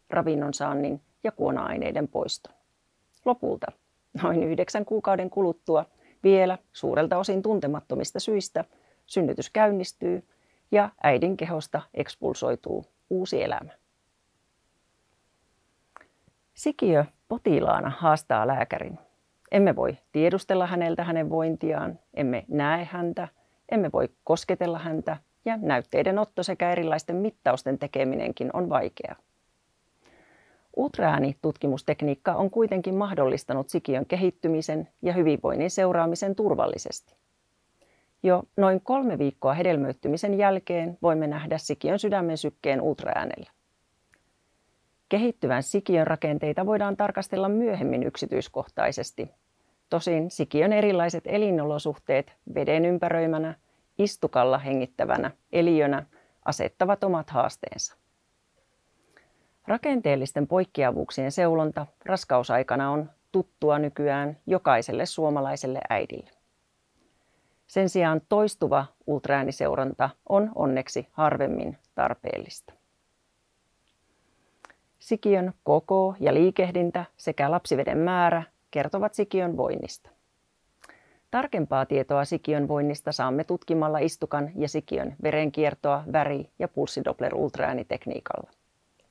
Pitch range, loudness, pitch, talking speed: 150-190 Hz, -26 LUFS, 165 Hz, 90 wpm